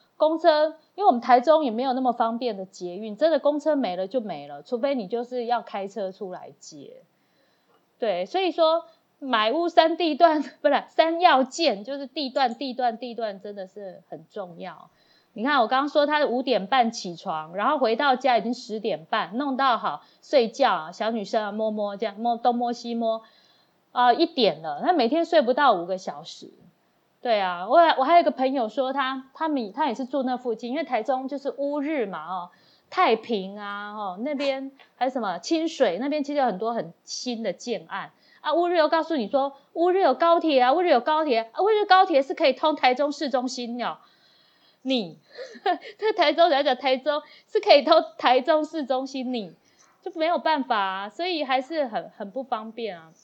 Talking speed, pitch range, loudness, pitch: 275 characters per minute, 230-310 Hz, -24 LUFS, 265 Hz